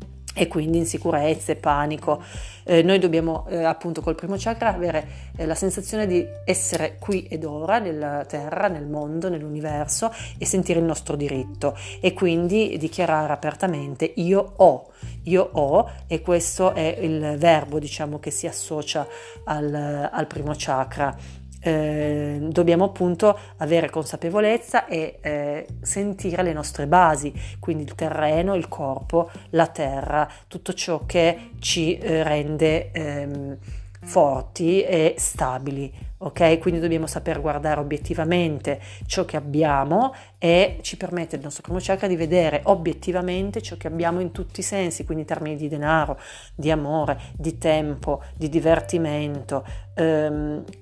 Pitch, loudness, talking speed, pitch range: 160 Hz, -23 LUFS, 140 wpm, 145-175 Hz